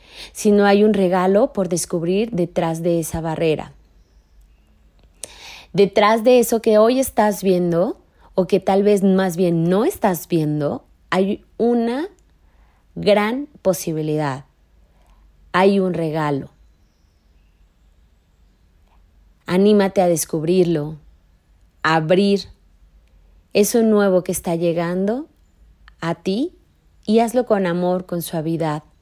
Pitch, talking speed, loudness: 175 Hz, 110 wpm, -18 LUFS